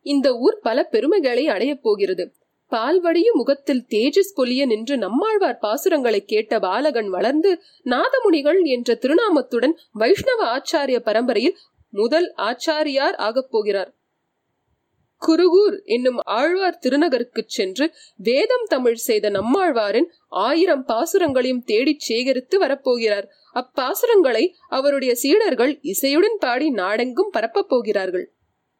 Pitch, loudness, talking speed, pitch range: 300 Hz, -19 LUFS, 100 wpm, 250-365 Hz